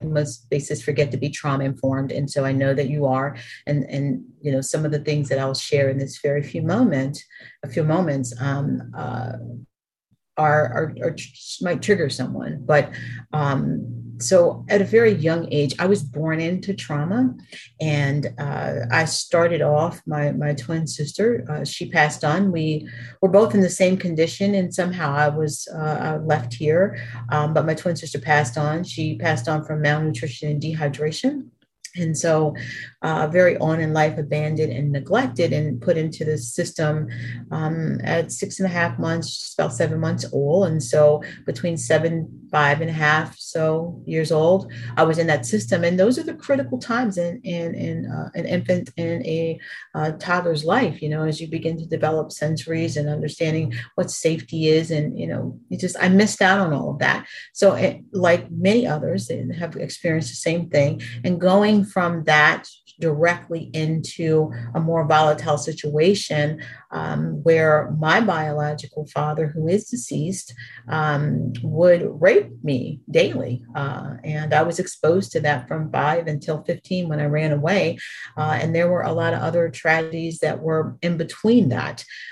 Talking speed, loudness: 175 wpm, -21 LUFS